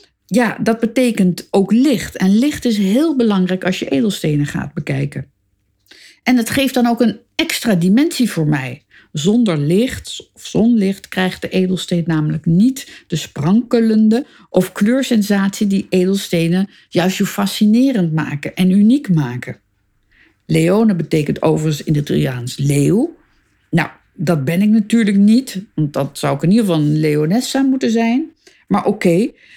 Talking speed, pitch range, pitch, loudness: 150 wpm, 160-230 Hz, 195 Hz, -16 LUFS